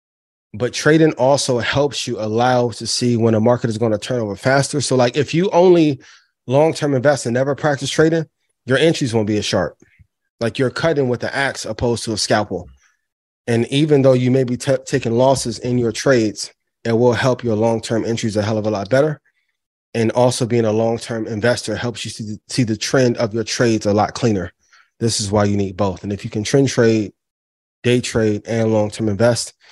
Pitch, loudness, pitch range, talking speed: 120 Hz, -17 LUFS, 110-135 Hz, 220 wpm